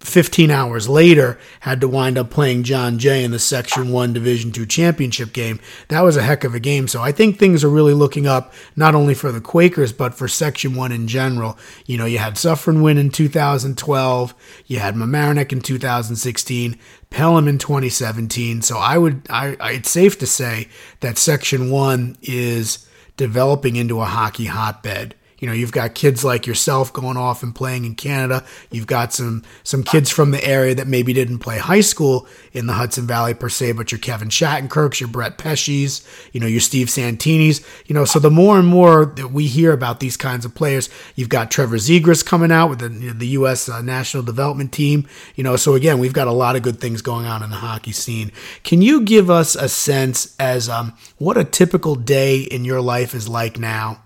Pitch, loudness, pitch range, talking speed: 130 Hz, -16 LUFS, 120-145 Hz, 210 wpm